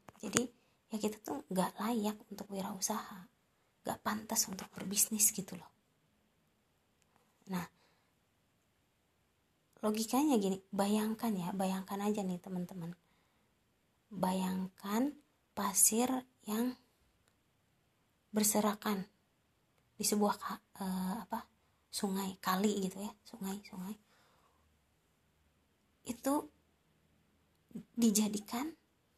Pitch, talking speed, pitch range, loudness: 205 Hz, 80 wpm, 185-220 Hz, -36 LUFS